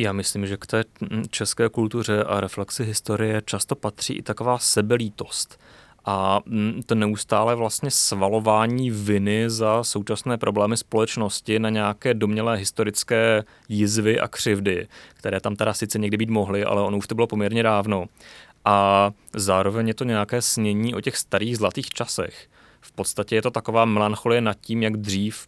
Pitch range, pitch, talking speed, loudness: 105-115 Hz, 110 Hz, 160 wpm, -23 LUFS